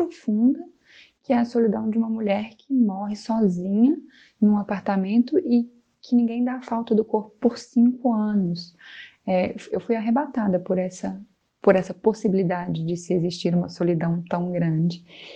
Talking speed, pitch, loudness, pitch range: 155 wpm, 215 Hz, -23 LUFS, 185-240 Hz